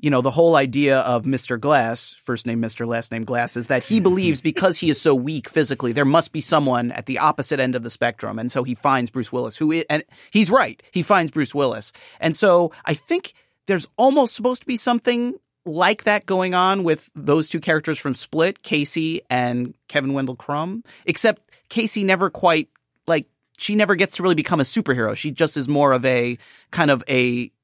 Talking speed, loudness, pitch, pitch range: 210 wpm, -20 LUFS, 150 Hz, 130-185 Hz